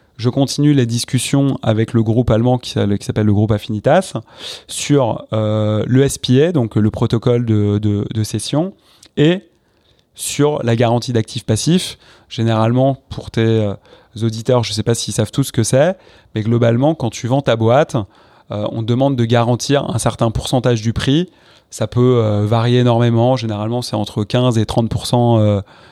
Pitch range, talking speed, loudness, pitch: 110-130 Hz, 175 wpm, -16 LUFS, 120 Hz